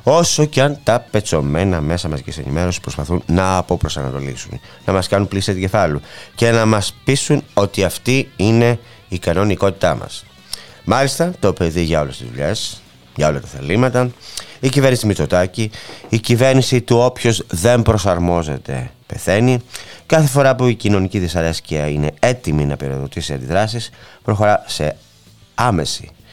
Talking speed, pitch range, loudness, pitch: 145 wpm, 85-120 Hz, -17 LUFS, 100 Hz